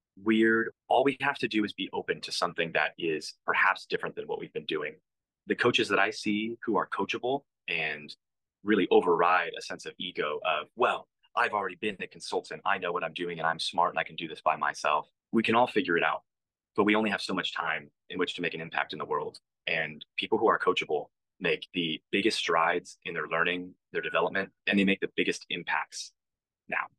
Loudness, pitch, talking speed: -29 LUFS, 110 Hz, 220 wpm